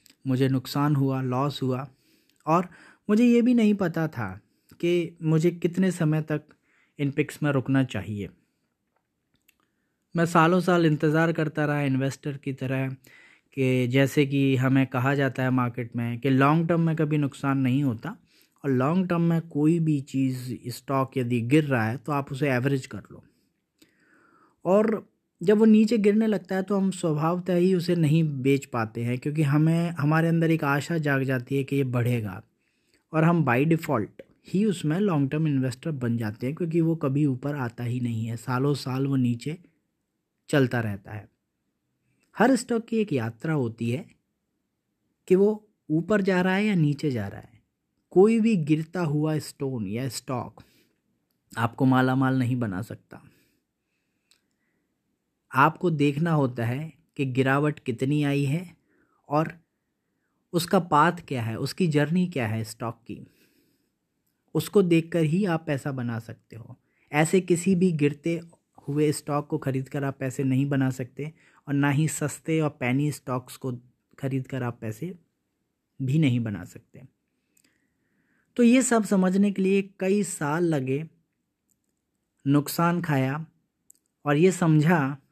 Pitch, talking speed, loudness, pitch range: 145 Hz, 155 wpm, -25 LUFS, 130-170 Hz